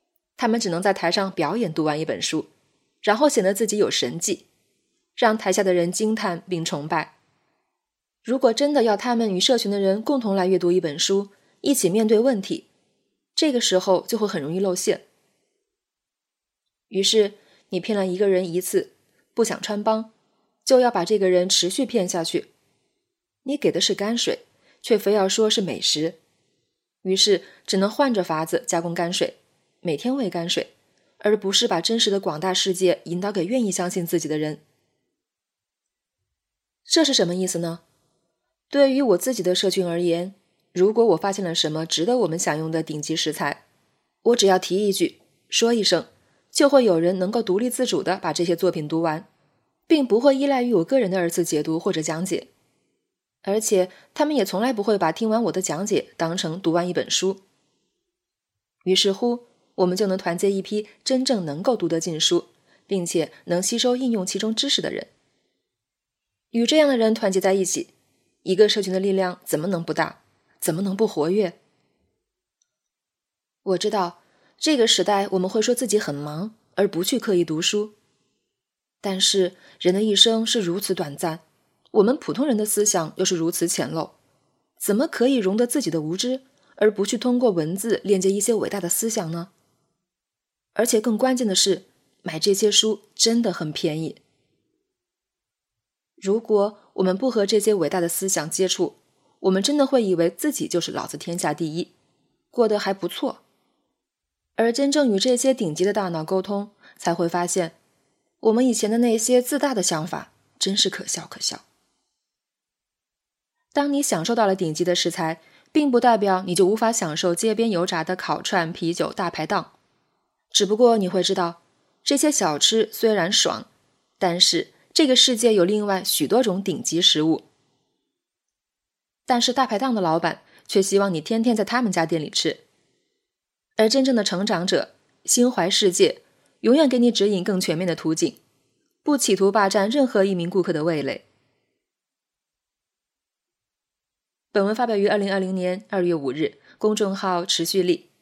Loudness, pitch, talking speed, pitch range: -21 LUFS, 195 Hz, 250 characters per minute, 175-230 Hz